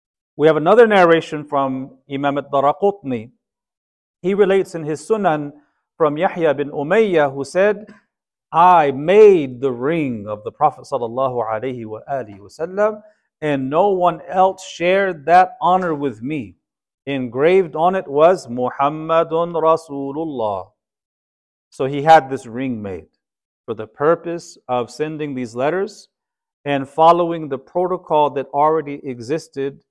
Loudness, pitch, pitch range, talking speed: -17 LUFS, 155 Hz, 135-180 Hz, 120 wpm